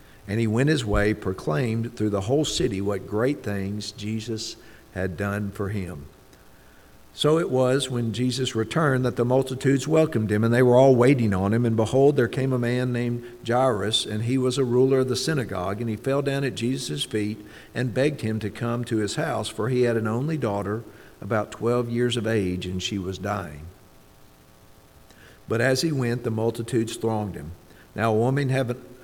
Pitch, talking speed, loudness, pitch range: 115 Hz, 195 wpm, -24 LUFS, 105-130 Hz